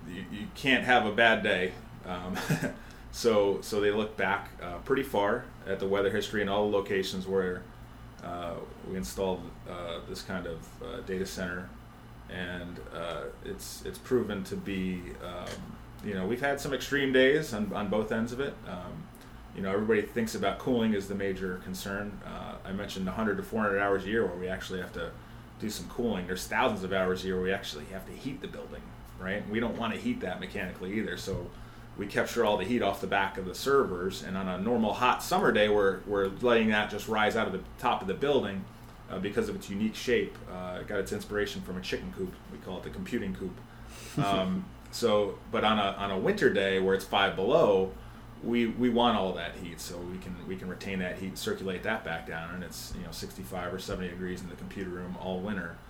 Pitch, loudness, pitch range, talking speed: 100 Hz, -31 LUFS, 95-110 Hz, 220 wpm